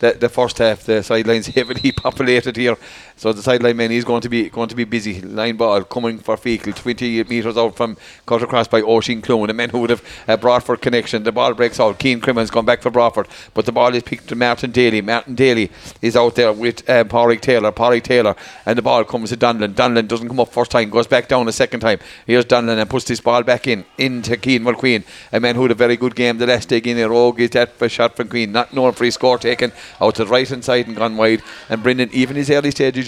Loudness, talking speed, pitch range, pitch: -16 LUFS, 260 wpm, 115-125 Hz, 120 Hz